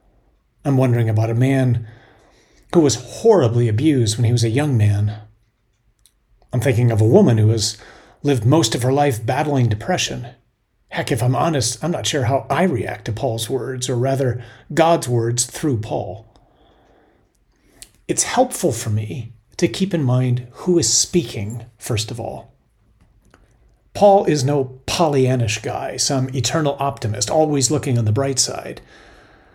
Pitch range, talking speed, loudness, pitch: 115-140 Hz, 155 wpm, -18 LUFS, 125 Hz